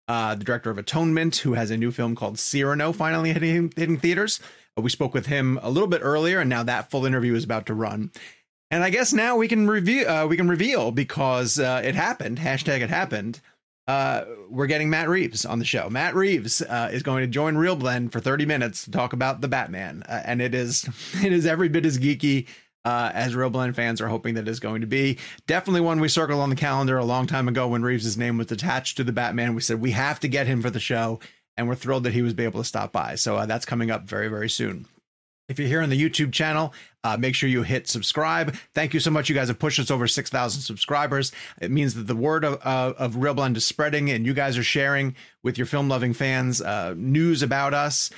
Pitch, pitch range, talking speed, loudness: 130 Hz, 120-150 Hz, 245 wpm, -24 LUFS